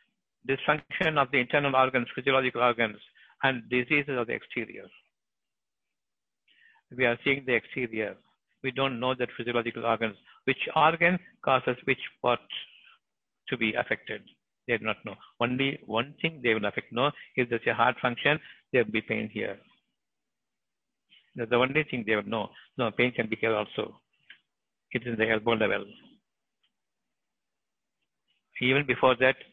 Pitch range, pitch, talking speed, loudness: 115-135 Hz, 125 Hz, 150 wpm, -28 LUFS